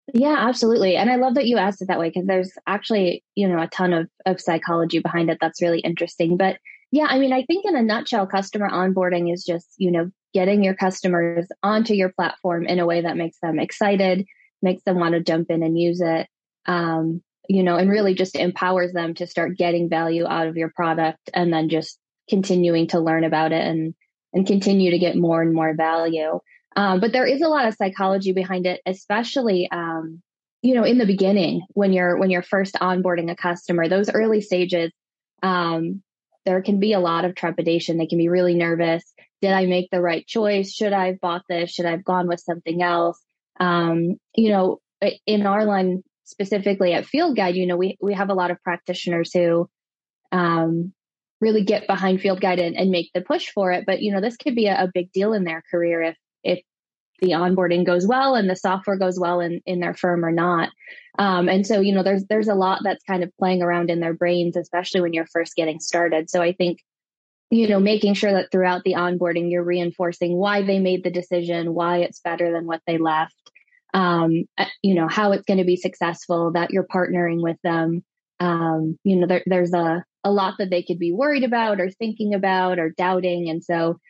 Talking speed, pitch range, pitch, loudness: 215 wpm, 170-195 Hz, 180 Hz, -21 LUFS